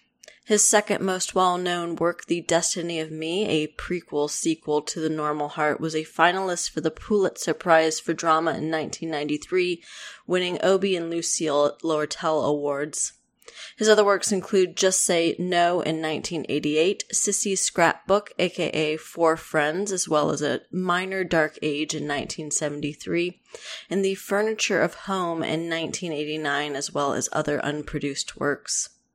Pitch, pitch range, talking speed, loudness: 165 Hz, 155-190 Hz, 145 wpm, -24 LUFS